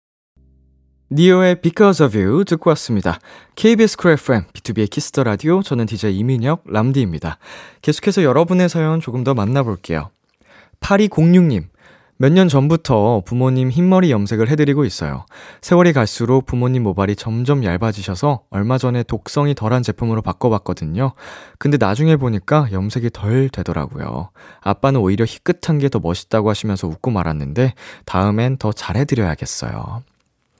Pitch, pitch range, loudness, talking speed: 125 Hz, 100-150 Hz, -17 LUFS, 355 characters per minute